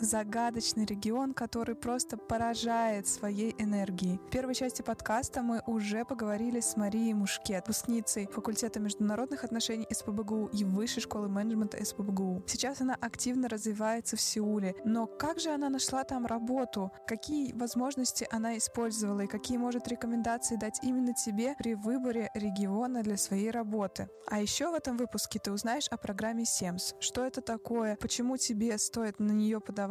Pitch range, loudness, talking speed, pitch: 210-240 Hz, -33 LUFS, 155 wpm, 225 Hz